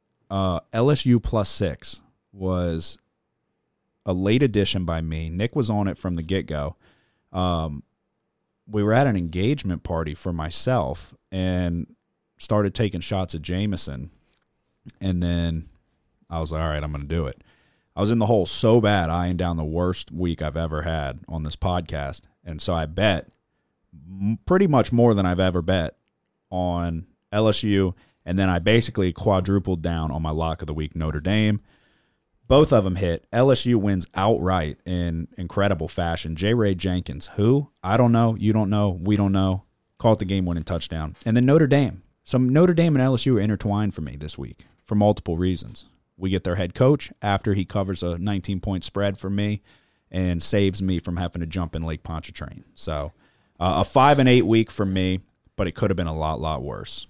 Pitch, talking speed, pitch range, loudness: 95 Hz, 185 wpm, 85-105 Hz, -23 LUFS